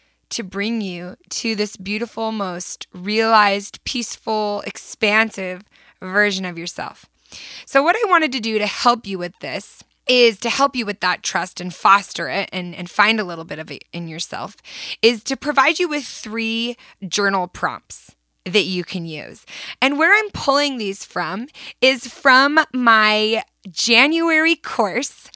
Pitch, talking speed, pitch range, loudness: 215 Hz, 160 wpm, 190-250 Hz, -18 LUFS